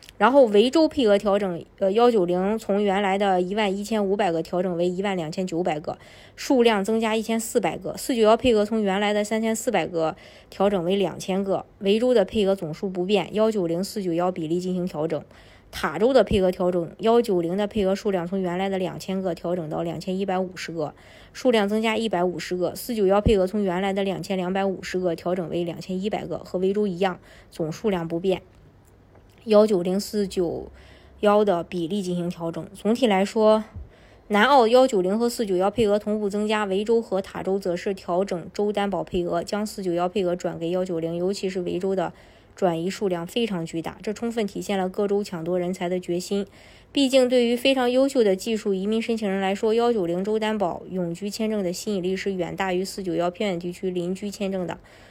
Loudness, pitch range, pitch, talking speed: -24 LUFS, 180-210 Hz, 195 Hz, 320 characters per minute